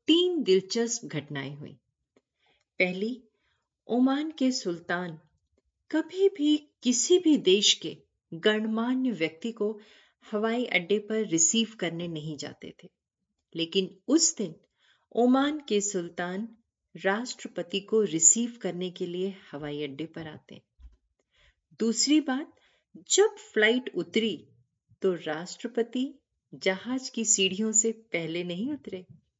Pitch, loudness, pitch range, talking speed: 210 Hz, -27 LUFS, 175-245 Hz, 110 wpm